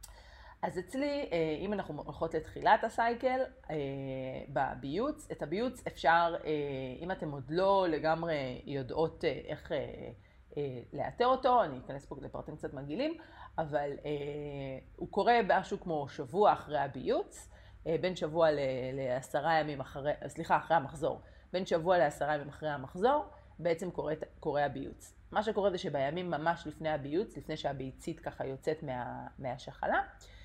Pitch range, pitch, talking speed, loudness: 145-180 Hz, 155 Hz, 130 wpm, -34 LUFS